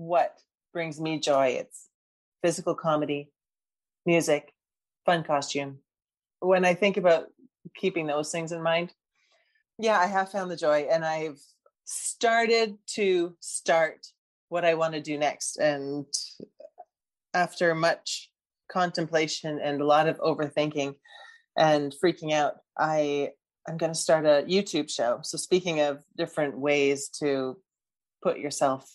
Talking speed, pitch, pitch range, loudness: 135 wpm, 160 Hz, 145-175 Hz, -27 LUFS